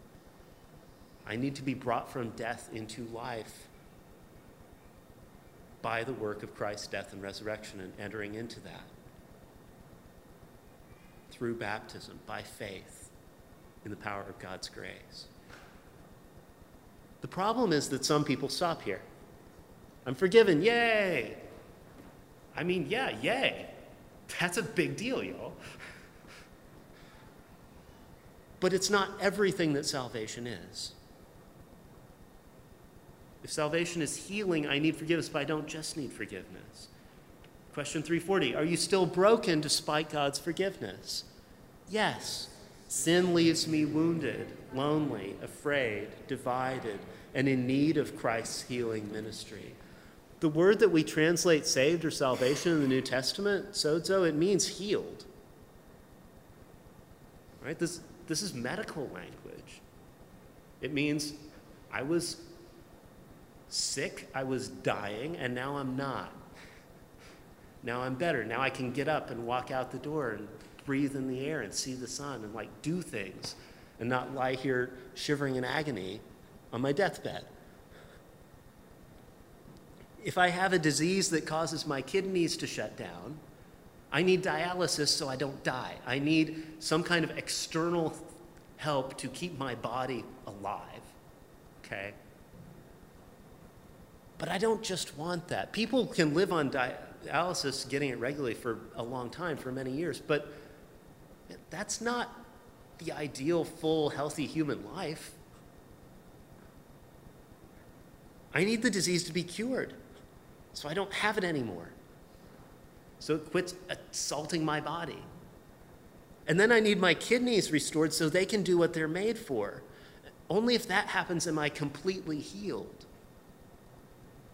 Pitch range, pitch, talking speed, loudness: 125-170 Hz, 150 Hz, 130 wpm, -32 LUFS